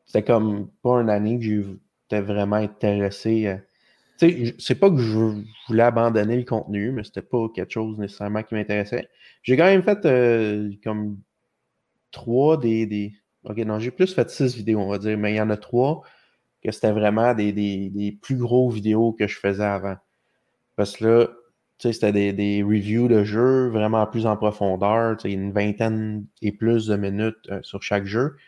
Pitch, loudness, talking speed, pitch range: 110 Hz, -22 LUFS, 190 wpm, 105-120 Hz